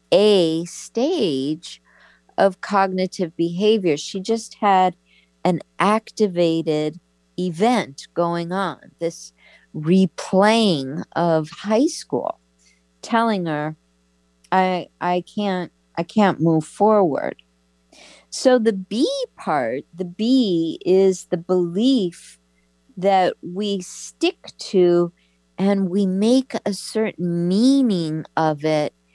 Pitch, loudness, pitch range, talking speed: 180 Hz, -20 LUFS, 155-205 Hz, 100 wpm